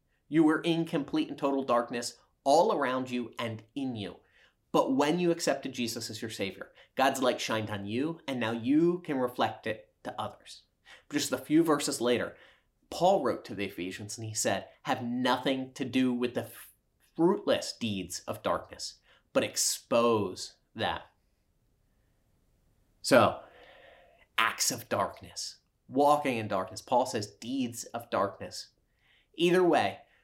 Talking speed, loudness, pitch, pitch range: 150 wpm, -30 LUFS, 125 Hz, 110-145 Hz